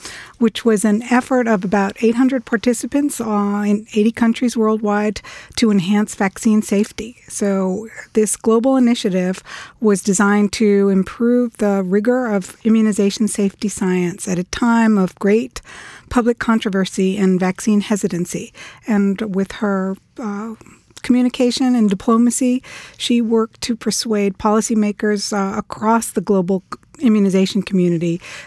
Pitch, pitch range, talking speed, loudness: 215 Hz, 200-230 Hz, 125 wpm, -17 LUFS